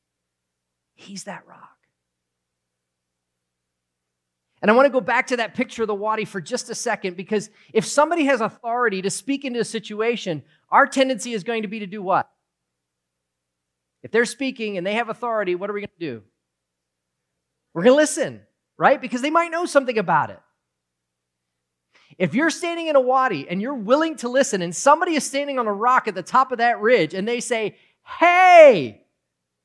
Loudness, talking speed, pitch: -20 LUFS, 185 wpm, 210 Hz